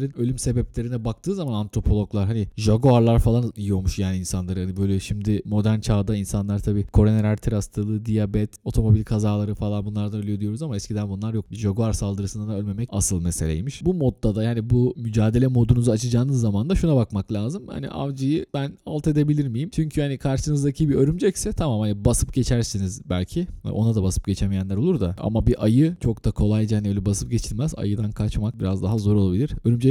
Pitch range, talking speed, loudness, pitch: 105-125 Hz, 180 wpm, -23 LUFS, 110 Hz